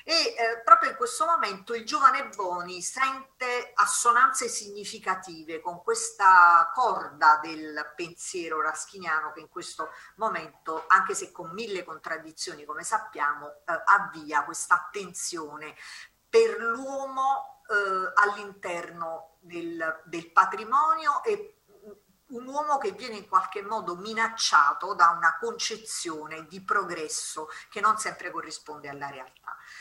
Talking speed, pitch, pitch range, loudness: 120 wpm, 195 Hz, 165-255 Hz, -26 LUFS